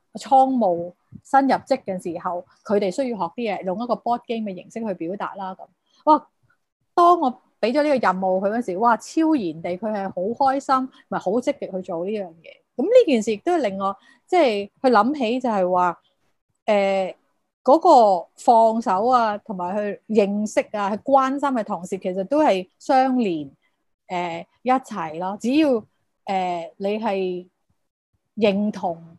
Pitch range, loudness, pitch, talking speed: 185-260 Hz, -21 LUFS, 215 Hz, 250 characters per minute